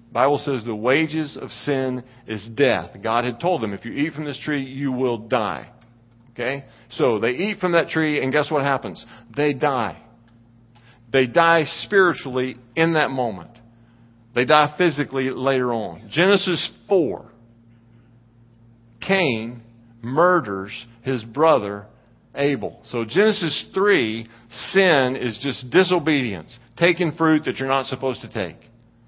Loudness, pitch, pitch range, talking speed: -21 LUFS, 125 Hz, 115-150 Hz, 140 wpm